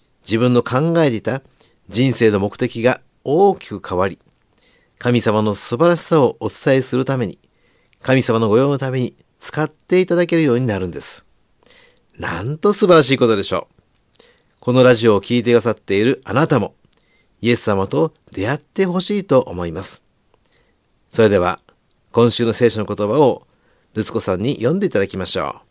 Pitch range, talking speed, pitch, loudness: 110-150 Hz, 335 characters per minute, 120 Hz, -17 LUFS